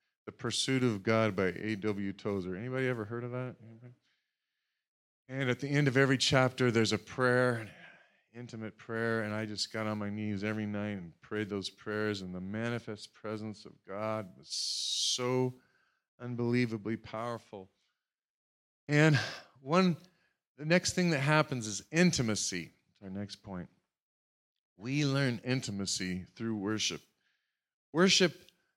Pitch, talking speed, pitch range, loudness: 115 Hz, 140 wpm, 105-130 Hz, -32 LUFS